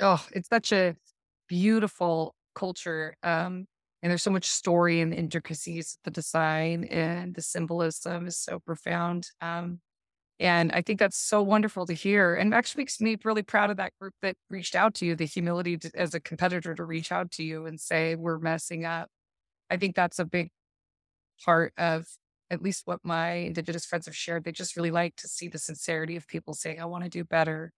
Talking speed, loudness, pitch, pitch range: 205 wpm, -29 LUFS, 170 Hz, 165-180 Hz